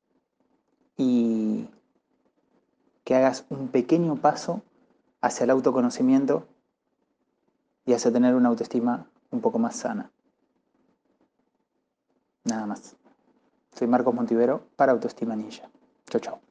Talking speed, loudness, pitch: 100 wpm, -25 LUFS, 145 Hz